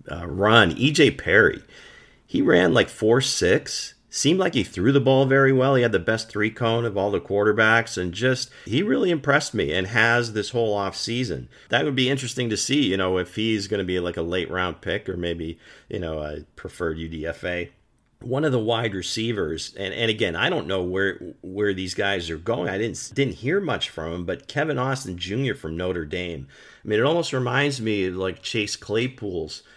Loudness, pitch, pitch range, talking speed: -23 LUFS, 105 Hz, 90-125 Hz, 210 wpm